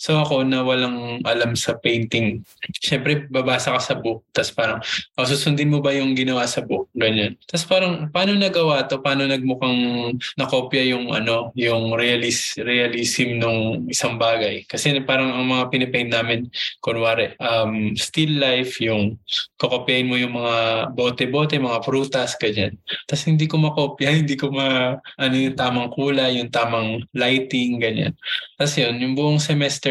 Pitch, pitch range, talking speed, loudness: 125 Hz, 120-140 Hz, 155 wpm, -20 LUFS